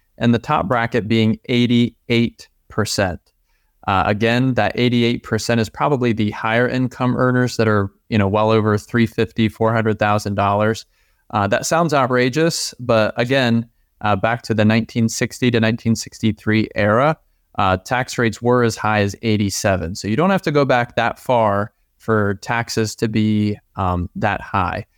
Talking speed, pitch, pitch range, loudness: 150 wpm, 115 Hz, 105-120 Hz, -18 LUFS